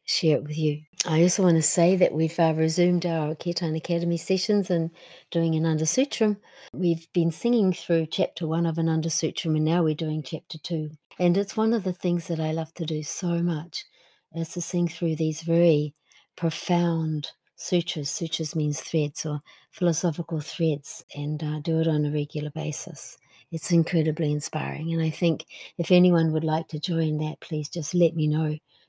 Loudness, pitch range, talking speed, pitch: -25 LUFS, 155-175 Hz, 185 wpm, 165 Hz